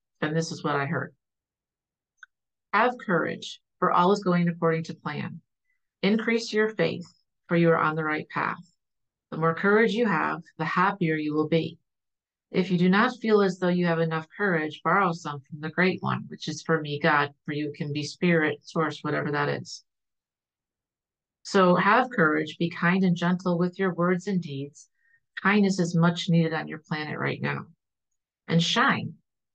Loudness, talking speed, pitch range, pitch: -25 LUFS, 180 wpm, 155-185 Hz, 165 Hz